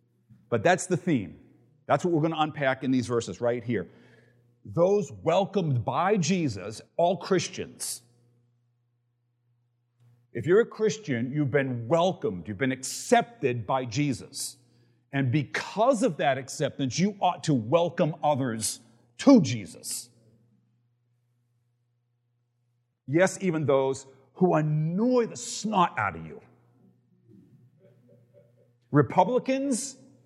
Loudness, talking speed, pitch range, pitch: -27 LUFS, 110 wpm, 120-165 Hz, 130 Hz